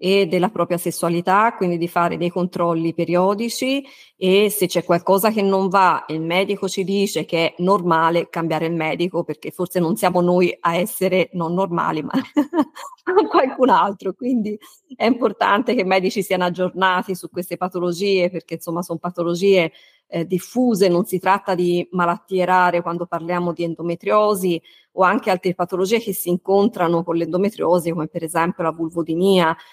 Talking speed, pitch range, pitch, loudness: 160 wpm, 170-195 Hz, 180 Hz, -19 LUFS